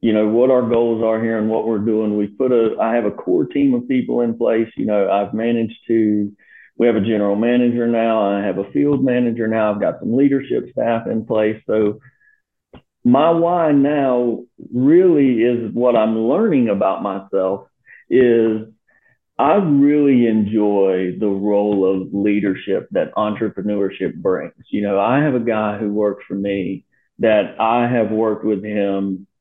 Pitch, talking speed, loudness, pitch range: 110 Hz, 175 wpm, -17 LUFS, 105-125 Hz